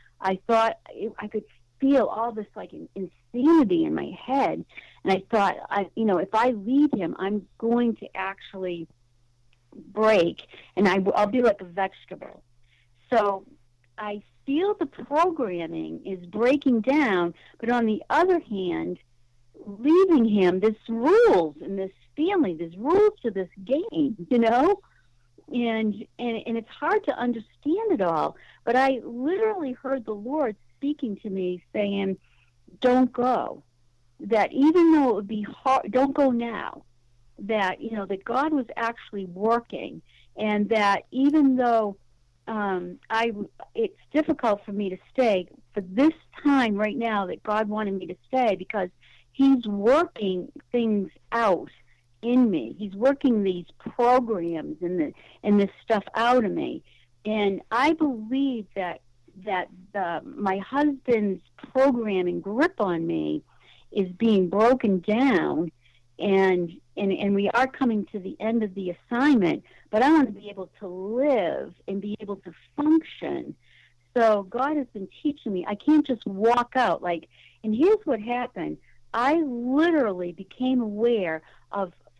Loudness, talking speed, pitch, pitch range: -25 LUFS, 150 wpm, 215 Hz, 190-260 Hz